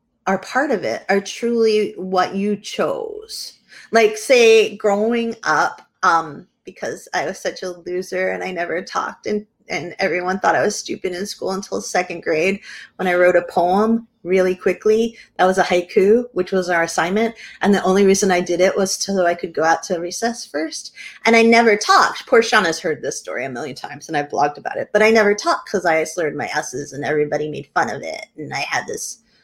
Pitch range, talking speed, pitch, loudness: 180-225 Hz, 210 wpm, 195 Hz, -18 LUFS